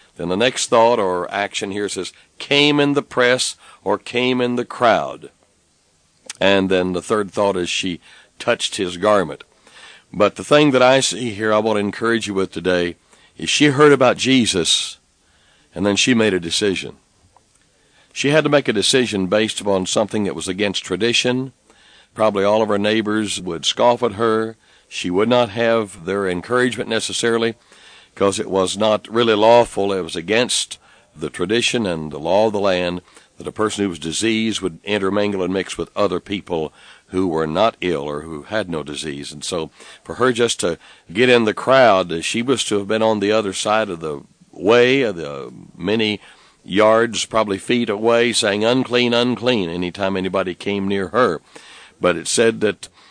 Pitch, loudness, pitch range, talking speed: 105 Hz, -18 LUFS, 95-120 Hz, 185 wpm